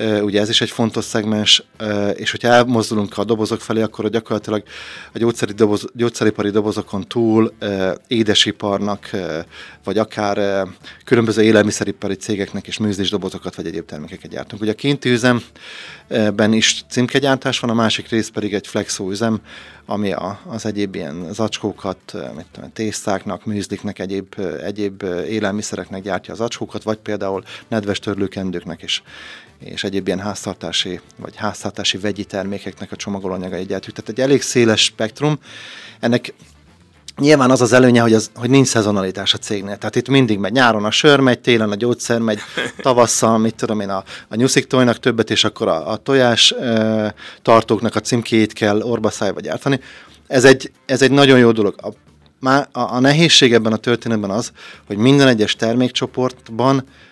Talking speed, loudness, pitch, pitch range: 155 wpm, -17 LUFS, 110 Hz, 100-120 Hz